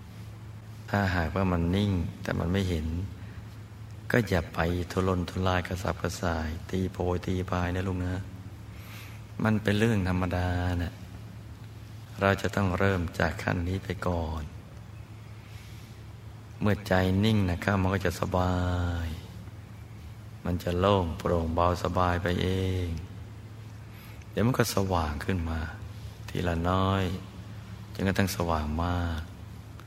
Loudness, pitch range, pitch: -29 LUFS, 90-105 Hz, 95 Hz